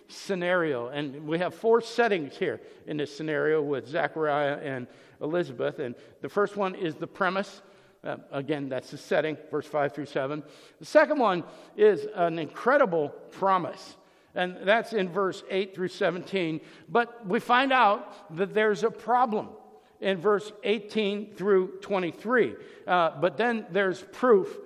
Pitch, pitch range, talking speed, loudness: 190 Hz, 155-210 Hz, 150 wpm, -27 LUFS